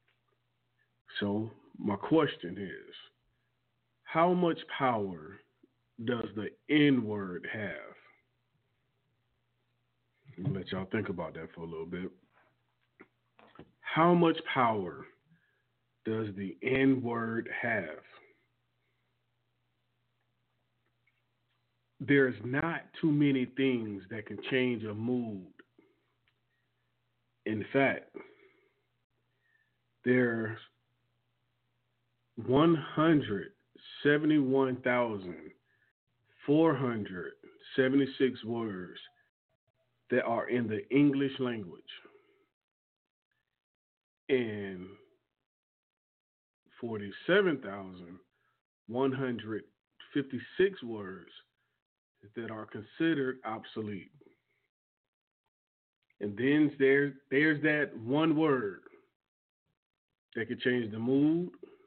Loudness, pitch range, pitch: -31 LUFS, 110-140 Hz, 125 Hz